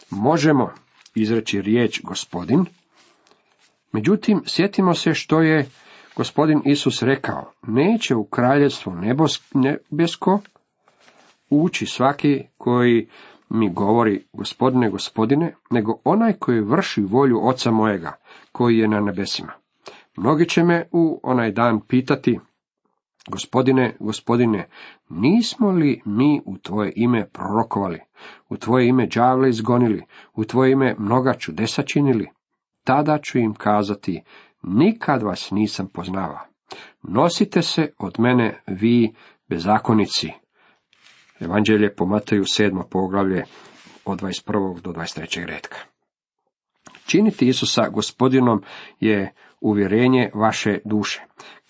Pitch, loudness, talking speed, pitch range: 120 Hz, -20 LUFS, 110 wpm, 105-145 Hz